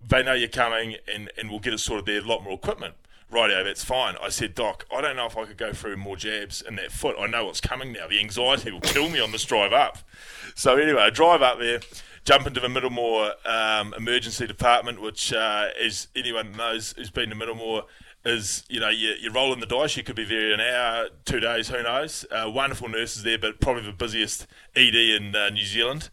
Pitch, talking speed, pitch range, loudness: 115 Hz, 230 wpm, 110-125 Hz, -24 LUFS